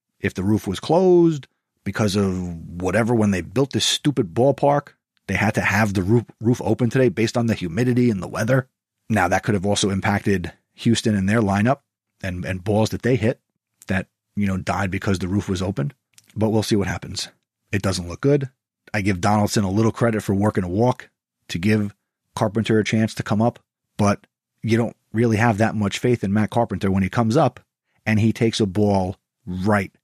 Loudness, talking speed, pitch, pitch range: -21 LUFS, 205 wpm, 110 Hz, 100-115 Hz